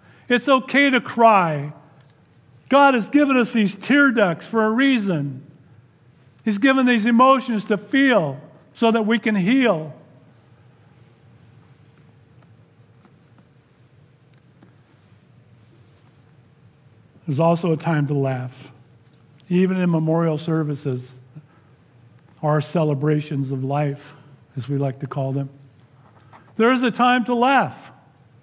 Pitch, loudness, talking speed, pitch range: 145 Hz, -19 LUFS, 110 wpm, 130-205 Hz